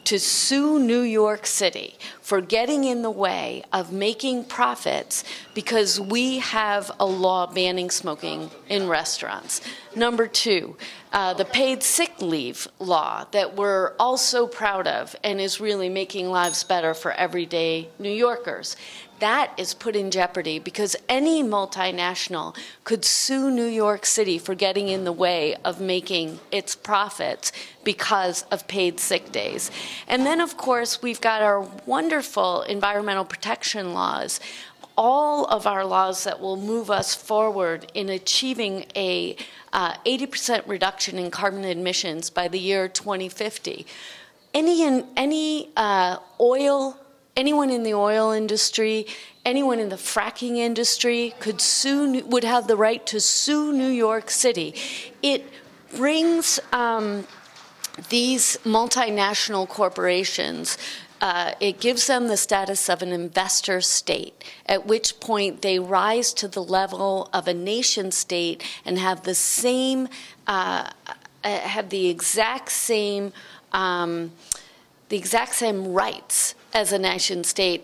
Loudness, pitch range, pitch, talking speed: -23 LUFS, 190-245 Hz, 210 Hz, 135 wpm